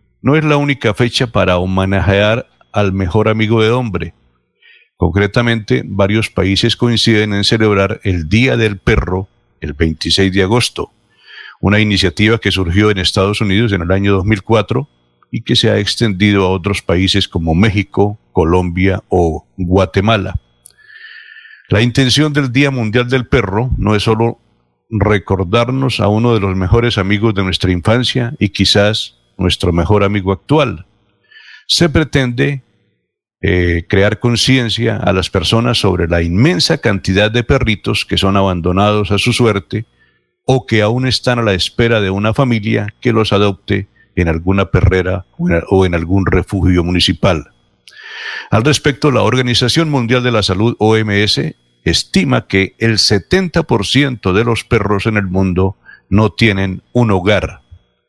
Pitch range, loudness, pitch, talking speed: 95-120 Hz, -13 LUFS, 105 Hz, 145 wpm